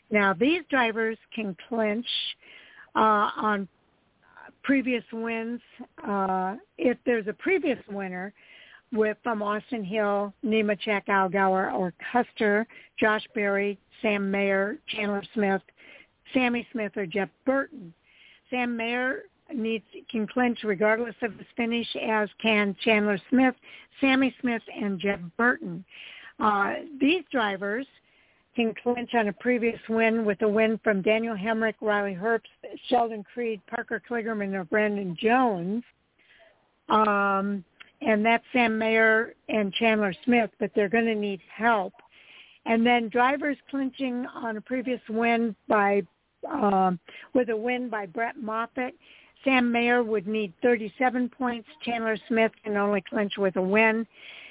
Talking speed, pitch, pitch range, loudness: 135 wpm, 225 Hz, 205-245 Hz, -26 LUFS